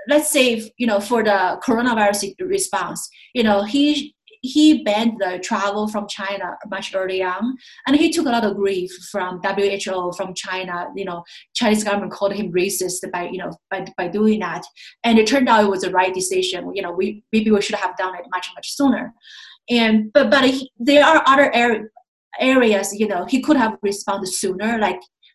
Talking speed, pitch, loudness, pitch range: 200 wpm, 210 Hz, -19 LUFS, 190-245 Hz